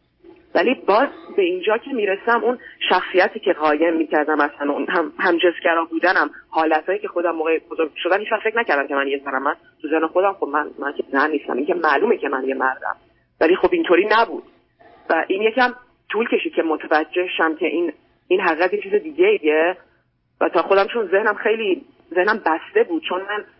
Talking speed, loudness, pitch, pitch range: 195 wpm, -19 LUFS, 185 Hz, 160-250 Hz